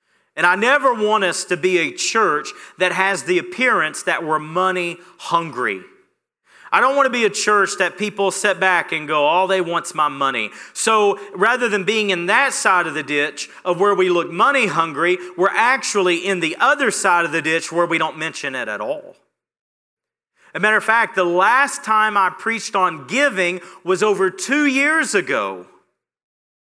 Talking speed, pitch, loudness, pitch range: 190 wpm, 185 Hz, -18 LUFS, 170-215 Hz